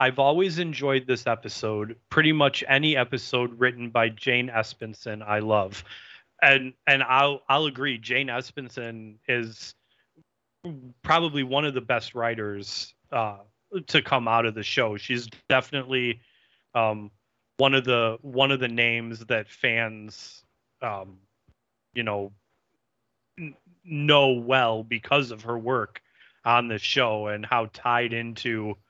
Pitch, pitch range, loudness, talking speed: 120 Hz, 110-135 Hz, -24 LUFS, 135 wpm